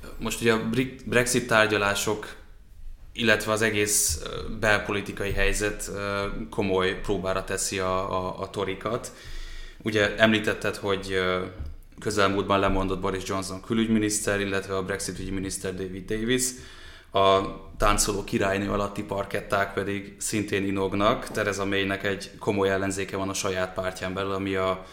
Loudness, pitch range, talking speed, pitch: -26 LUFS, 95-105 Hz, 125 wpm, 100 Hz